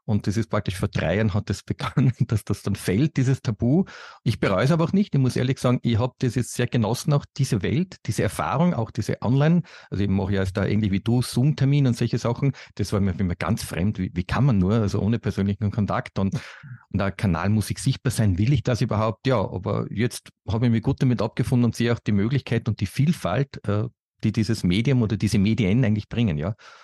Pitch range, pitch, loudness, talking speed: 105-130 Hz, 115 Hz, -23 LUFS, 240 wpm